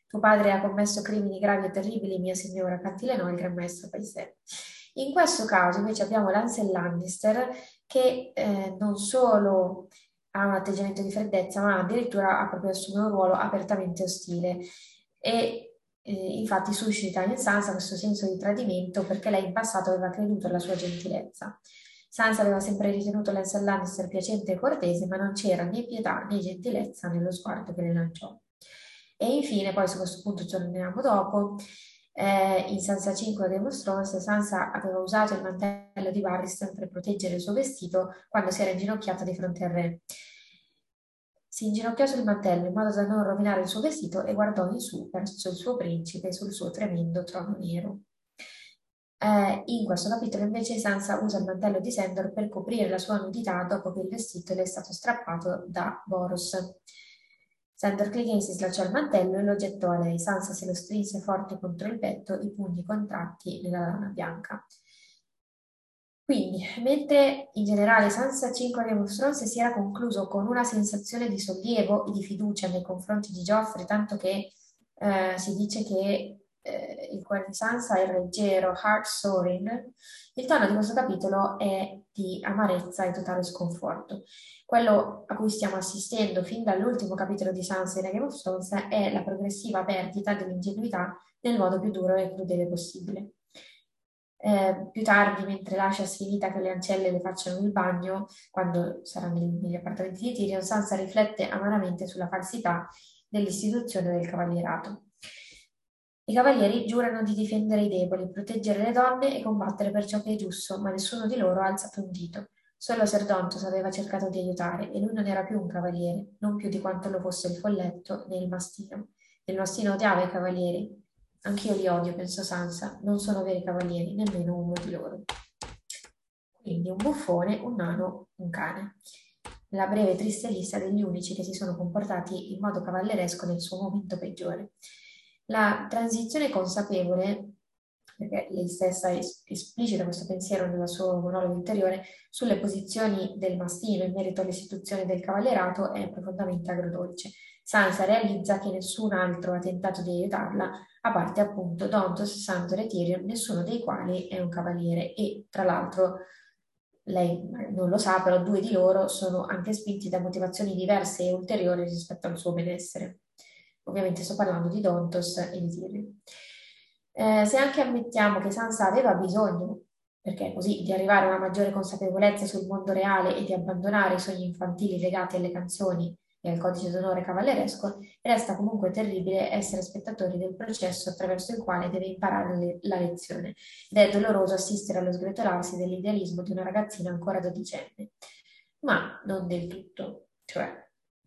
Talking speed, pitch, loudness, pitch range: 165 wpm, 195 Hz, -28 LUFS, 185-210 Hz